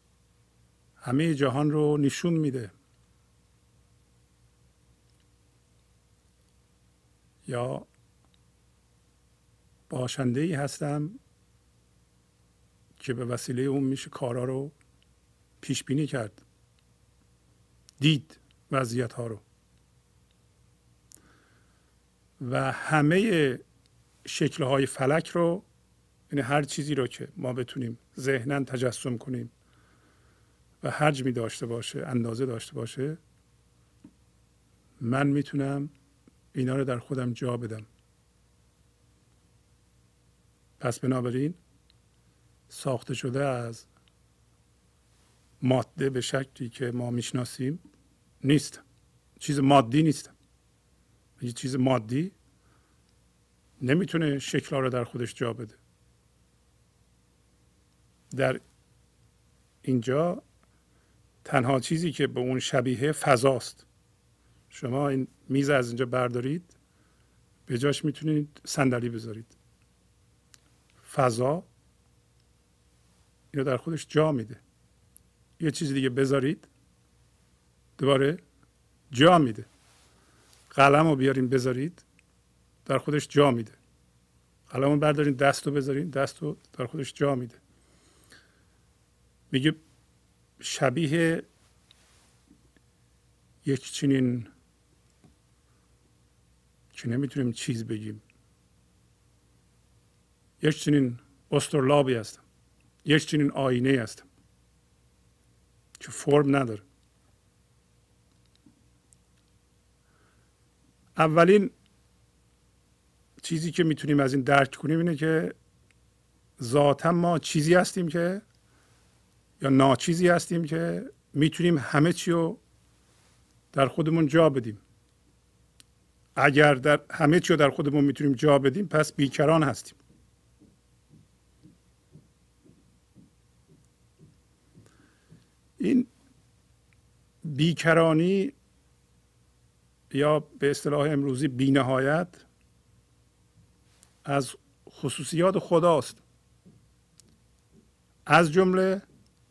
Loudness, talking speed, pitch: -26 LUFS, 80 wpm, 130 Hz